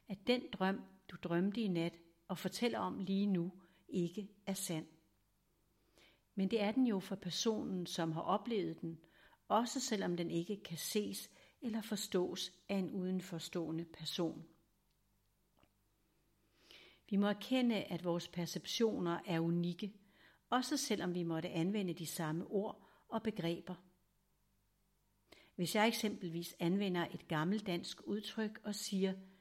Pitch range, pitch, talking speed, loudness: 170-210 Hz, 185 Hz, 135 wpm, -39 LUFS